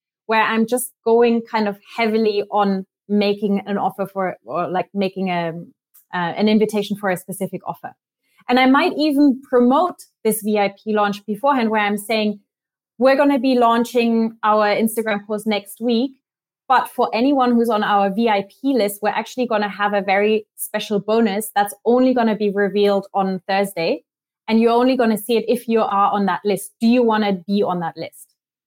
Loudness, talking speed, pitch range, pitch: -19 LUFS, 190 wpm, 200-230 Hz, 215 Hz